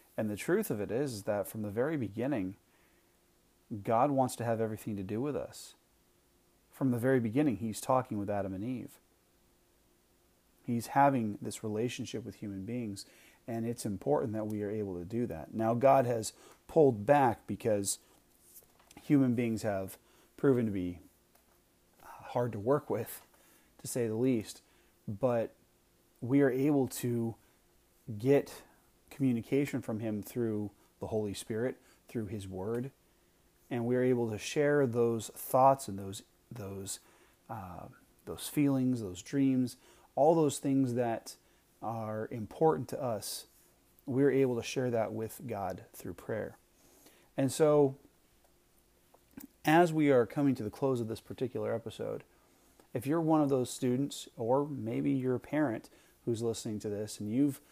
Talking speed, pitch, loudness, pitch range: 155 wpm, 115 Hz, -33 LUFS, 105-135 Hz